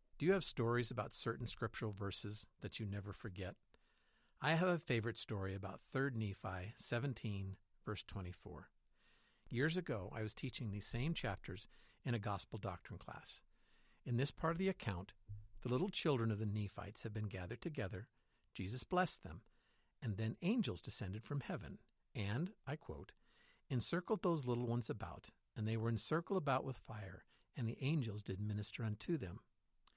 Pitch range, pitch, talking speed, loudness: 105-135 Hz, 115 Hz, 165 wpm, -43 LUFS